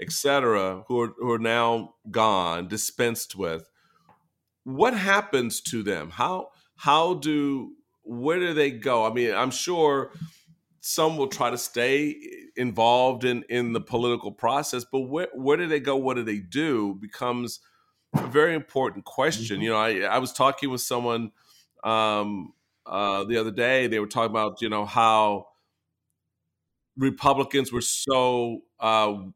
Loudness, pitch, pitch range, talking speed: -25 LUFS, 120 Hz, 110-140 Hz, 150 wpm